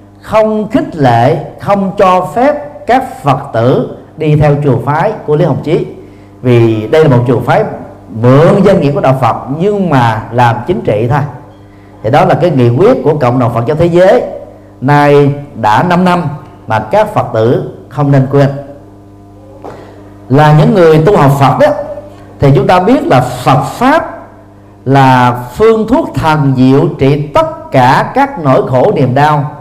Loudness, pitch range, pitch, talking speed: -9 LUFS, 120-175 Hz, 140 Hz, 175 wpm